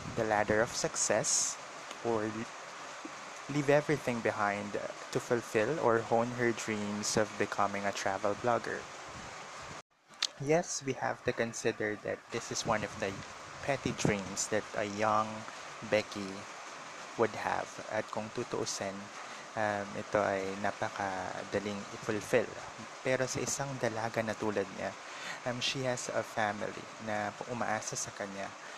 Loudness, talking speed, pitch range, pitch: -34 LUFS, 130 wpm, 105-120 Hz, 110 Hz